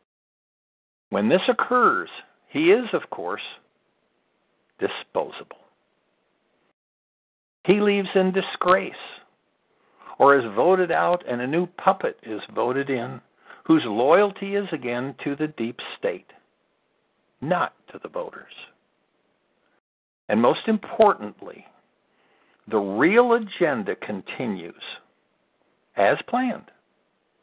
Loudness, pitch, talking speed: -23 LUFS, 200 Hz, 95 wpm